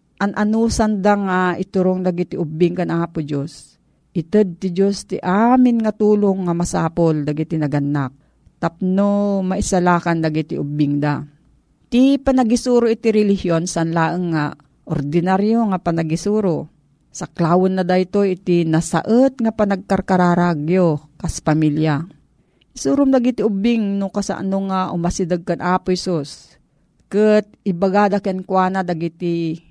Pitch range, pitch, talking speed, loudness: 165-205 Hz, 185 Hz, 120 wpm, -18 LUFS